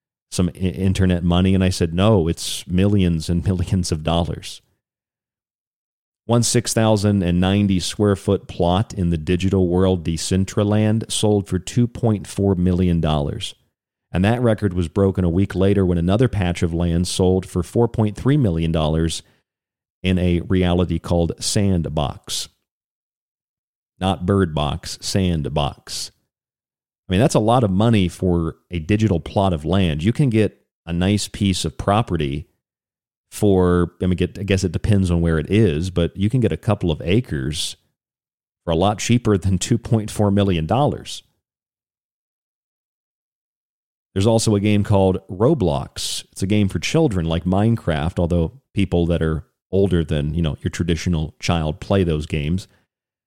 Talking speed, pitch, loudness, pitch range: 145 wpm, 95 Hz, -20 LUFS, 85-105 Hz